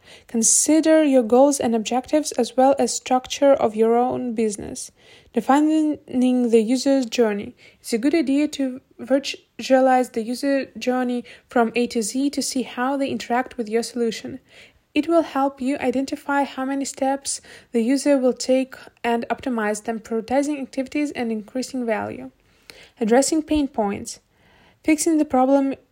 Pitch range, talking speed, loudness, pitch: 240-275 Hz, 150 wpm, -21 LUFS, 255 Hz